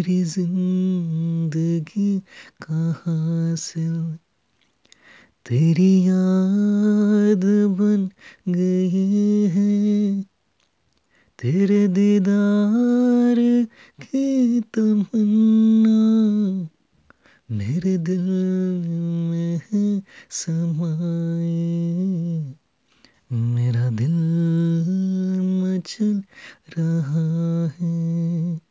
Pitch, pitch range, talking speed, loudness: 185 Hz, 165-205 Hz, 45 wpm, -20 LUFS